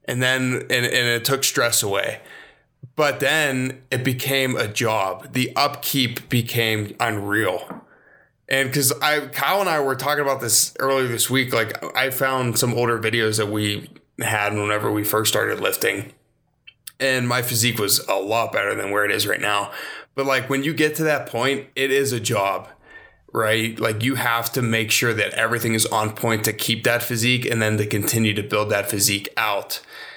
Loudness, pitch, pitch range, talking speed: -20 LUFS, 120 Hz, 110-135 Hz, 190 wpm